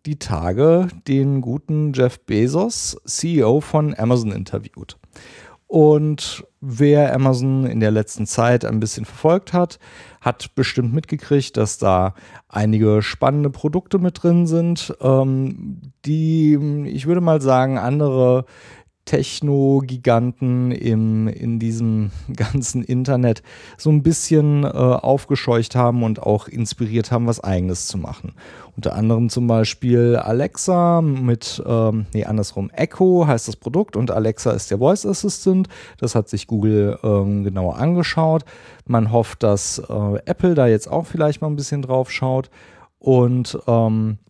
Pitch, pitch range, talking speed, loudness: 125 Hz, 110-150 Hz, 135 wpm, -18 LUFS